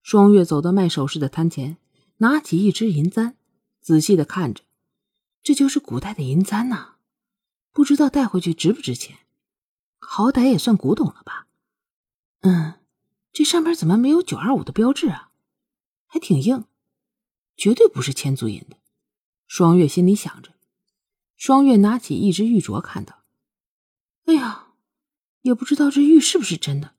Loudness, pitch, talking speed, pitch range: -19 LUFS, 205 Hz, 230 characters per minute, 170-265 Hz